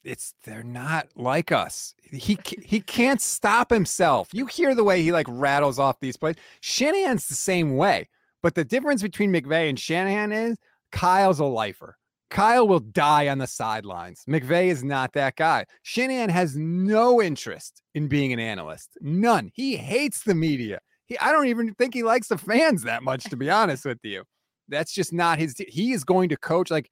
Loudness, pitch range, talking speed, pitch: -23 LUFS, 140-220 Hz, 190 wpm, 170 Hz